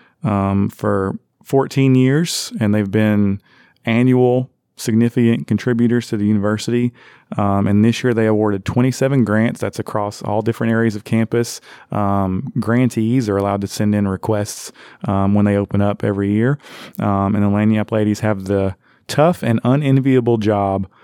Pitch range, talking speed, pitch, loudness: 100-120 Hz, 155 wpm, 110 Hz, -17 LUFS